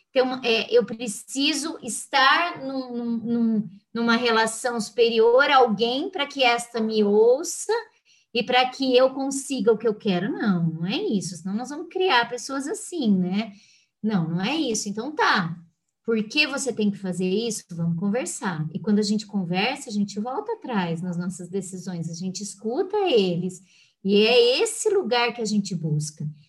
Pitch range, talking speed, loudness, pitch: 190-265 Hz, 170 wpm, -23 LUFS, 225 Hz